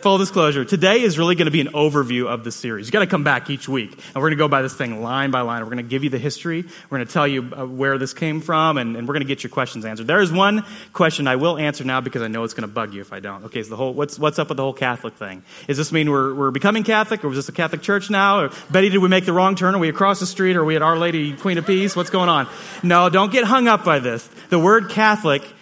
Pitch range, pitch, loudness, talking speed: 130-185 Hz, 150 Hz, -19 LUFS, 315 wpm